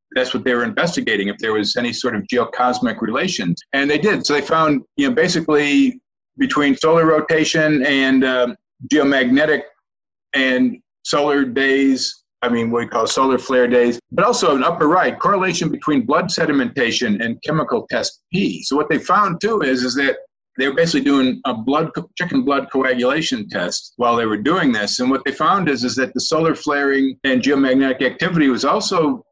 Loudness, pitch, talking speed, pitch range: -17 LUFS, 135 Hz, 185 wpm, 125-155 Hz